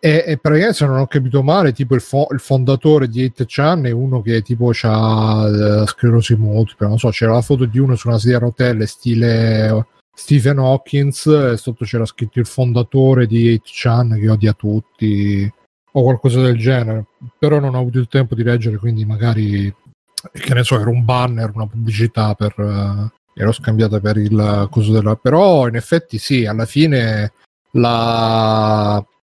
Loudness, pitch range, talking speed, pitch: -15 LUFS, 110-130 Hz, 180 wpm, 120 Hz